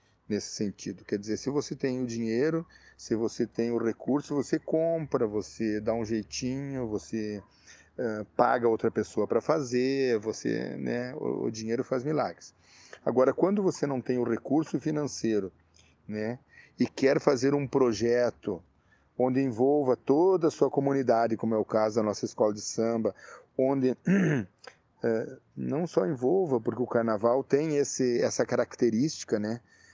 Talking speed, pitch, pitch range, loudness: 150 wpm, 120 Hz, 110-140 Hz, -29 LUFS